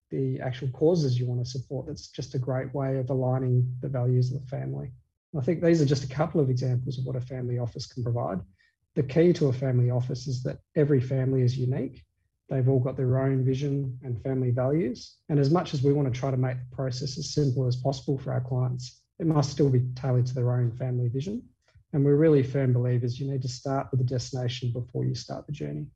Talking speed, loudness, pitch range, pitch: 235 wpm, -27 LUFS, 125-140 Hz, 130 Hz